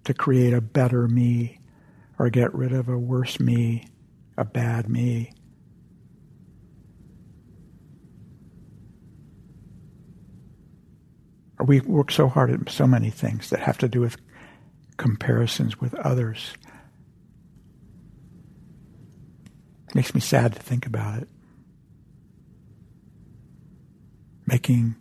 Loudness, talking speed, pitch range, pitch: -23 LUFS, 95 wpm, 120-130 Hz, 125 Hz